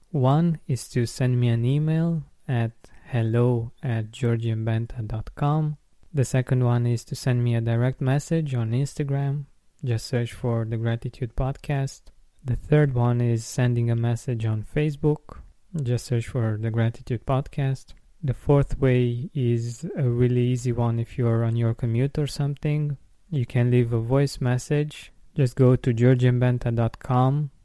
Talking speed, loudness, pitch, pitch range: 150 wpm, -24 LUFS, 125 Hz, 115-140 Hz